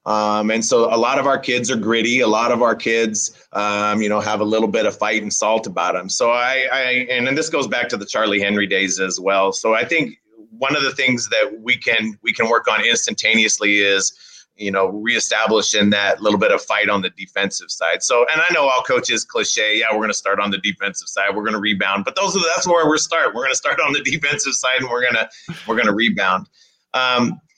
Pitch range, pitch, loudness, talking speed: 105-125 Hz, 110 Hz, -17 LUFS, 250 wpm